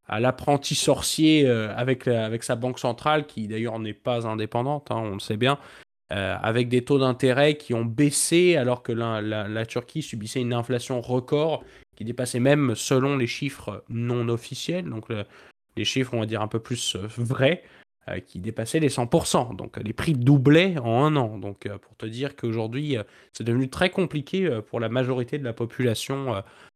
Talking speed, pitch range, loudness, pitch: 185 wpm, 115-140 Hz, -25 LUFS, 125 Hz